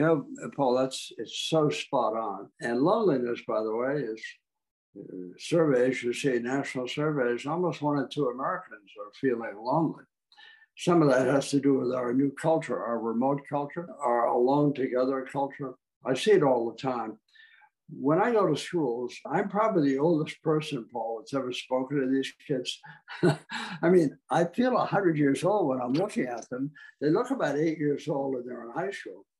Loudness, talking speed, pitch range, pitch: -28 LUFS, 185 wpm, 130-165 Hz, 140 Hz